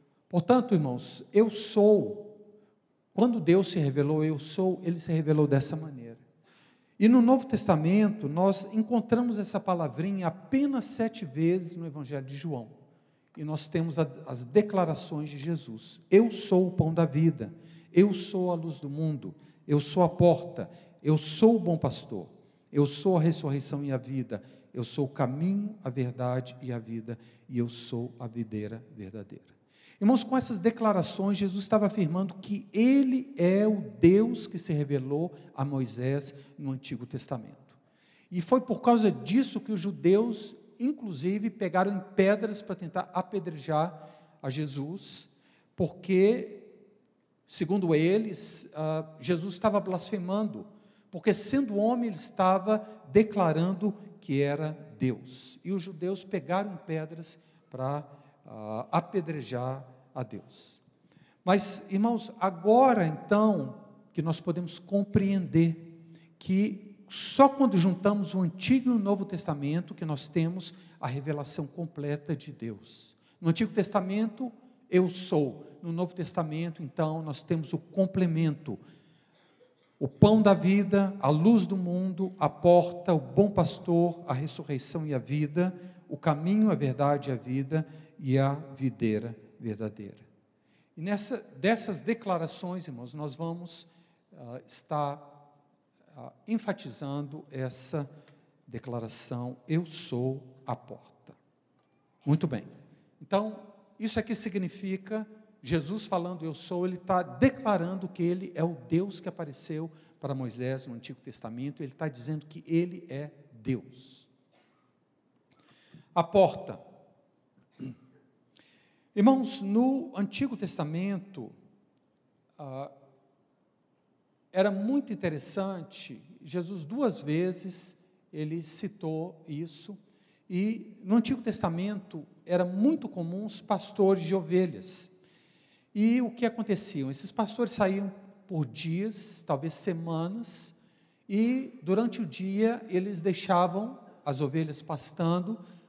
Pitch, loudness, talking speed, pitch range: 175 Hz, -29 LUFS, 125 wpm, 150-200 Hz